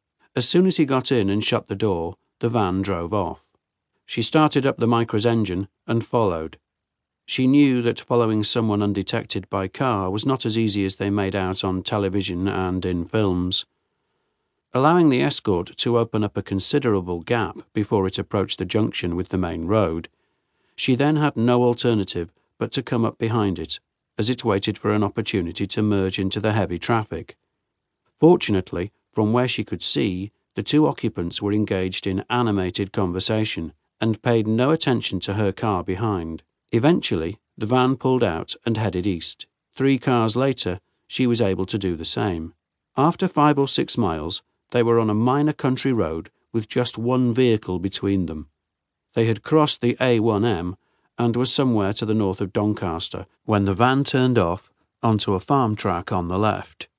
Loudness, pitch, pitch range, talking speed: -21 LUFS, 105 Hz, 95-120 Hz, 175 wpm